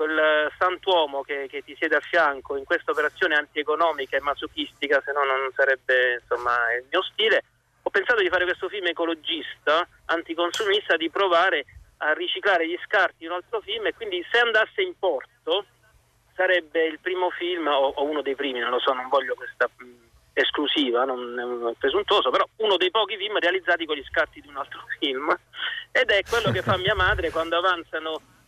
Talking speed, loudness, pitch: 190 wpm, -24 LUFS, 165 Hz